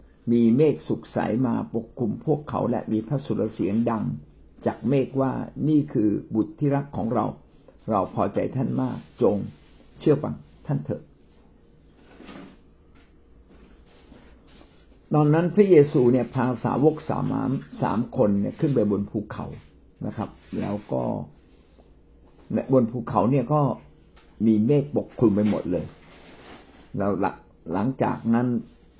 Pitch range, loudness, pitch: 105-140 Hz, -24 LUFS, 120 Hz